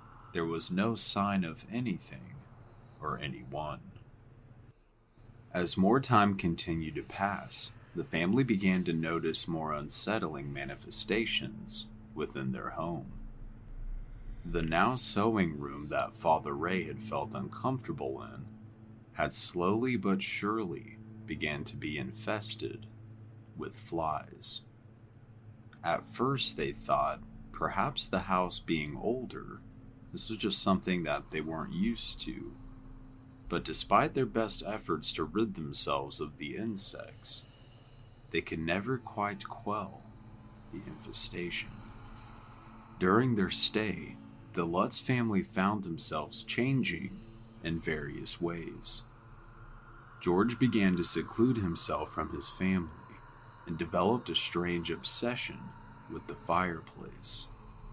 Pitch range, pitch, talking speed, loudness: 95-115 Hz, 110 Hz, 115 wpm, -32 LUFS